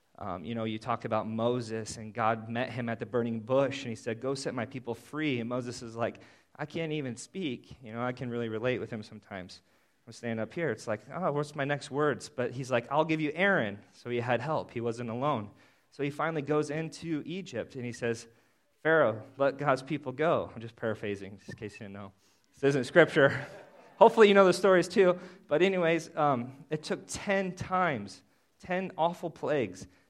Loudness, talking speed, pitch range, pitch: -30 LUFS, 215 wpm, 115-155 Hz, 130 Hz